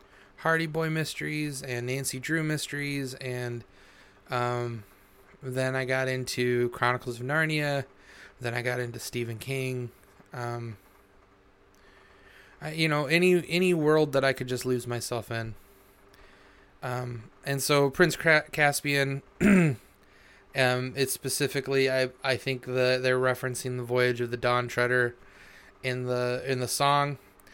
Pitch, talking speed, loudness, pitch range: 125 Hz, 135 wpm, -28 LUFS, 120-140 Hz